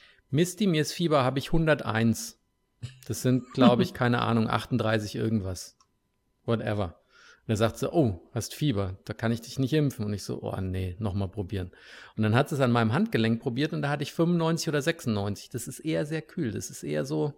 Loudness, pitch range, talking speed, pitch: -28 LUFS, 105-145 Hz, 210 wpm, 115 Hz